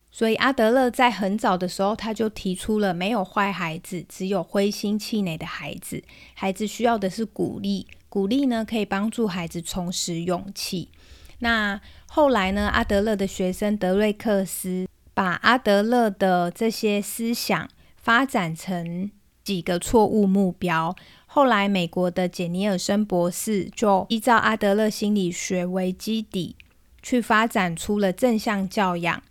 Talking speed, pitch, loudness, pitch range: 235 characters per minute, 200 Hz, -23 LUFS, 185-220 Hz